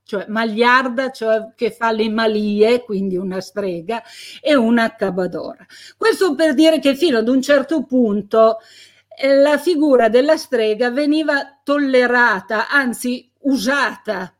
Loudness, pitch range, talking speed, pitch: -17 LUFS, 220-280 Hz, 130 wpm, 245 Hz